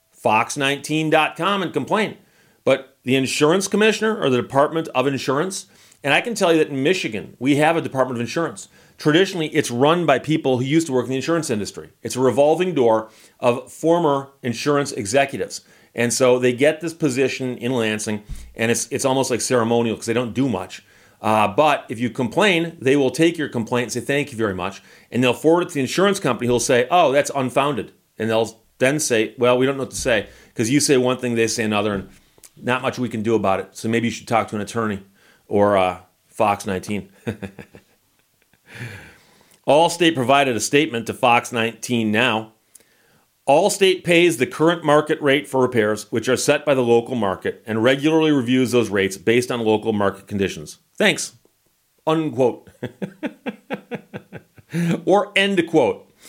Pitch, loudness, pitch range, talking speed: 130 Hz, -19 LUFS, 115-150 Hz, 185 wpm